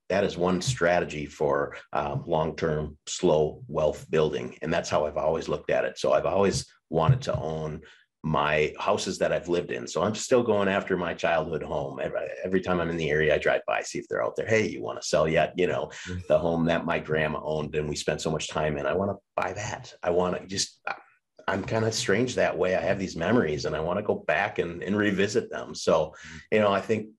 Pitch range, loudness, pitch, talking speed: 75-100 Hz, -27 LUFS, 85 Hz, 240 wpm